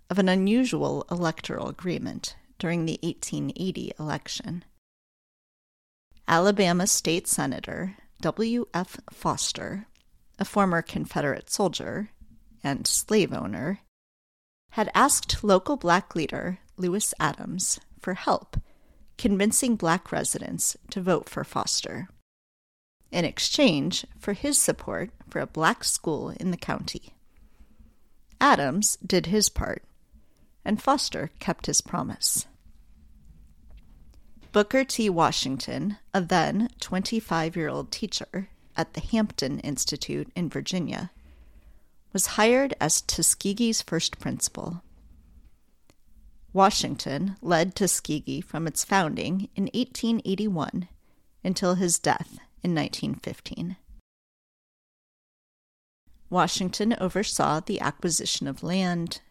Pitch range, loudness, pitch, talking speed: 140-205 Hz, -26 LUFS, 180 Hz, 100 wpm